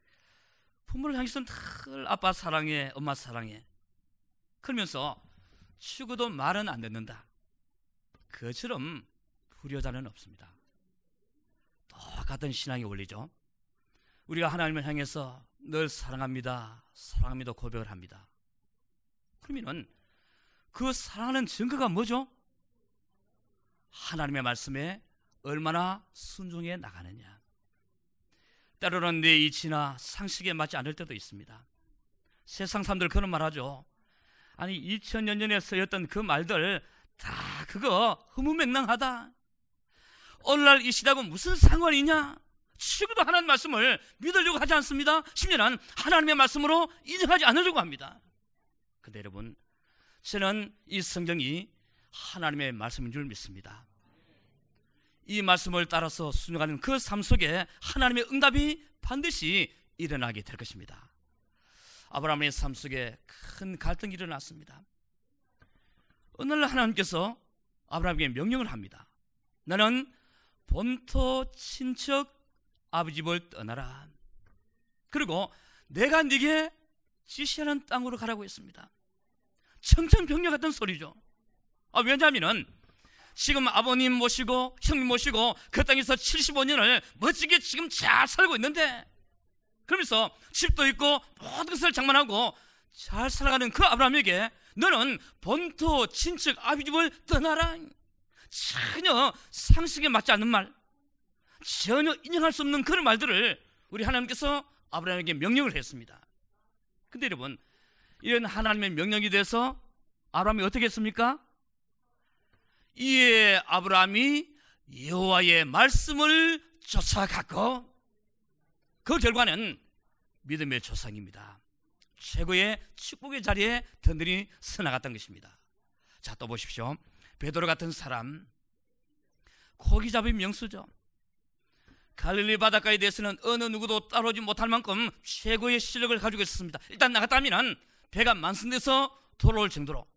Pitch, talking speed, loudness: 205 Hz, 270 characters per minute, -27 LUFS